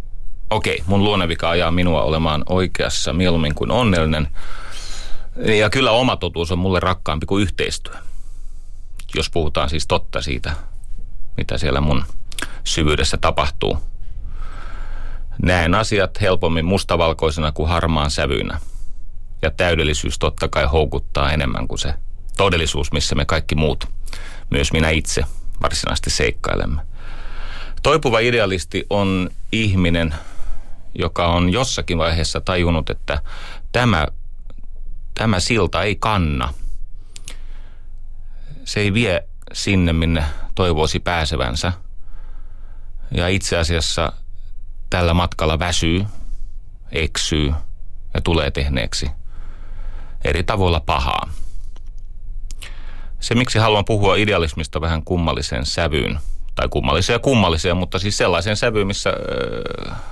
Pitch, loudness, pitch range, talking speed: 90 Hz, -19 LUFS, 80-95 Hz, 105 wpm